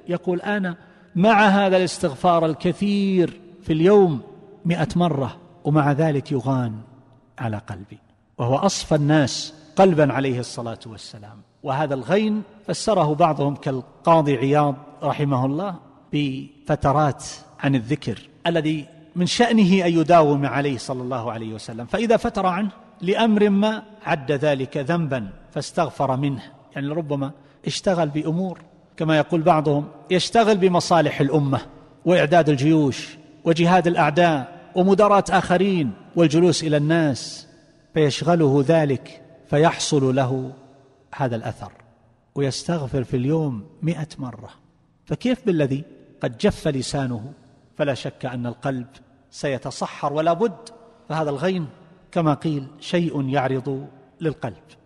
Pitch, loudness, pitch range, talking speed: 155 Hz, -21 LUFS, 135-175 Hz, 110 wpm